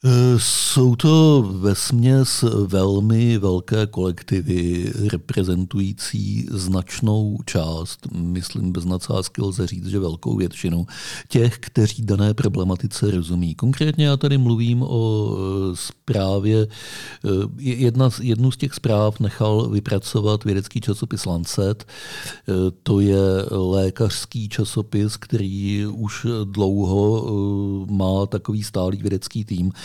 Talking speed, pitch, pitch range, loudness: 100 wpm, 105 Hz, 95-115 Hz, -20 LUFS